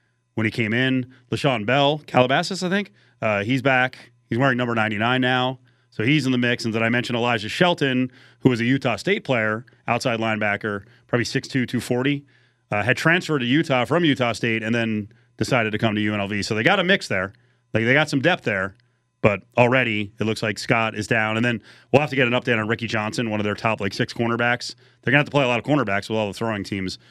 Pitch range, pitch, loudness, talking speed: 110-130 Hz, 120 Hz, -21 LUFS, 235 wpm